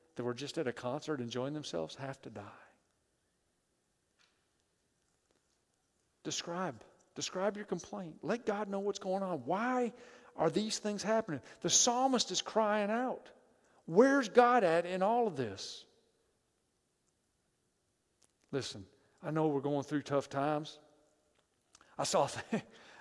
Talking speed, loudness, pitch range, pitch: 130 wpm, -34 LUFS, 140-210 Hz, 165 Hz